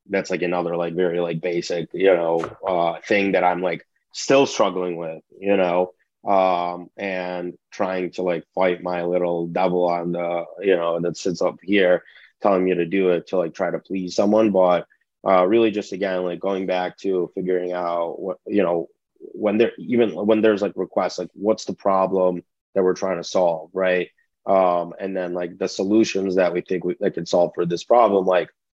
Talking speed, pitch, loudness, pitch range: 195 wpm, 90 Hz, -21 LUFS, 85-95 Hz